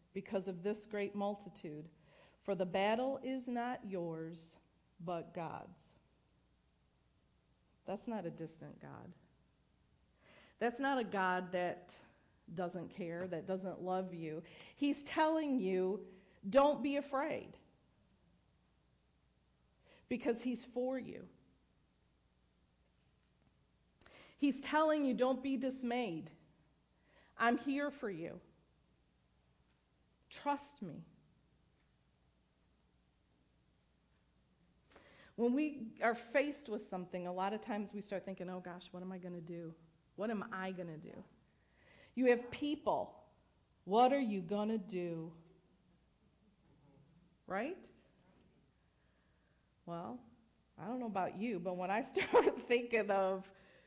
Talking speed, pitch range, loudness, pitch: 110 wpm, 165-240 Hz, -39 LUFS, 190 Hz